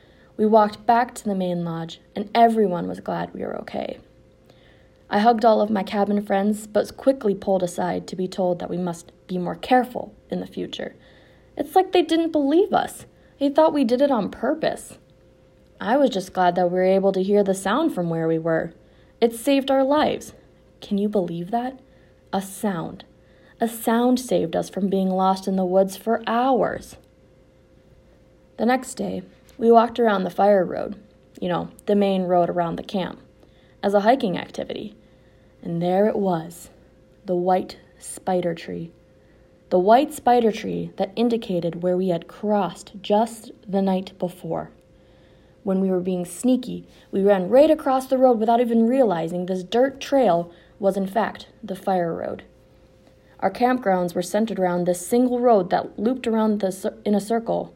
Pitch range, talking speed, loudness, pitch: 180-235 Hz, 175 wpm, -22 LUFS, 205 Hz